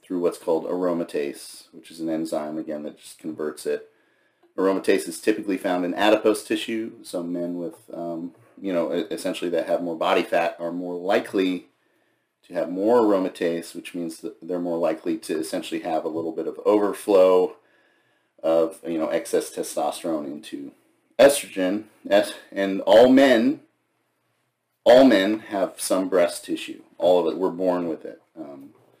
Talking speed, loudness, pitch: 160 wpm, -23 LUFS, 110 Hz